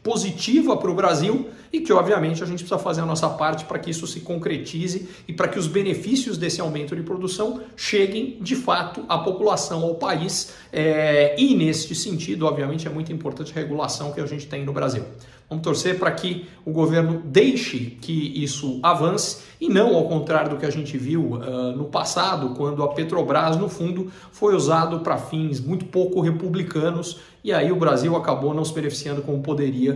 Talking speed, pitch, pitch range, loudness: 185 wpm, 165 Hz, 150-185 Hz, -23 LUFS